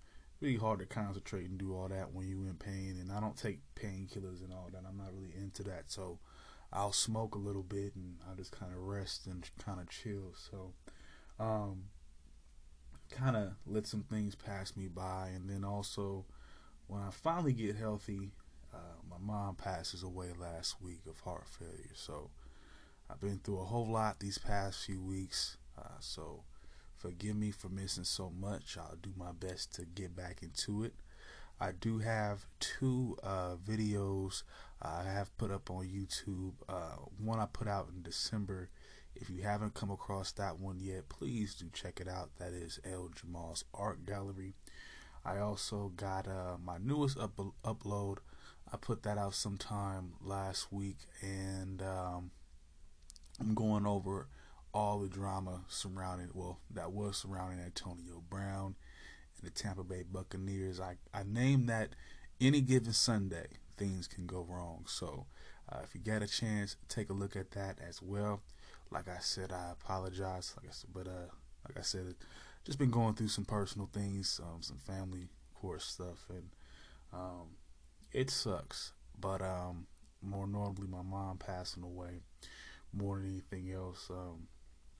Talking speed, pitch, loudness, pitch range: 165 wpm, 95 Hz, -41 LUFS, 90-100 Hz